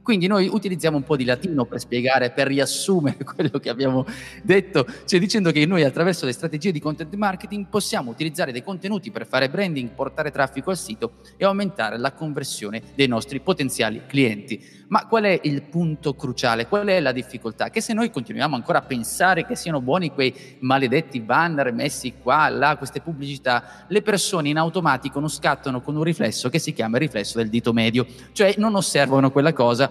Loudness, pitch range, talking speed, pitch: -22 LUFS, 130-185 Hz, 190 wpm, 145 Hz